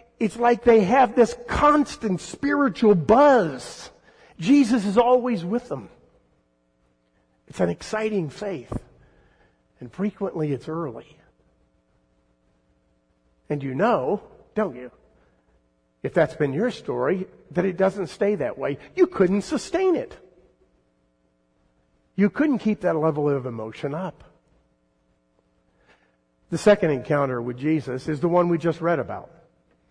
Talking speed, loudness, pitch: 120 wpm, -22 LUFS, 155 Hz